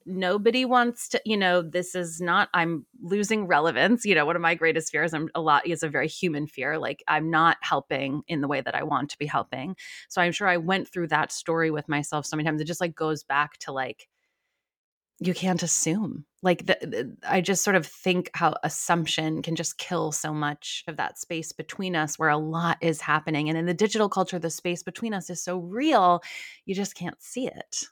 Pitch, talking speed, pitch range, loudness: 170 Hz, 225 wpm, 155-185 Hz, -26 LUFS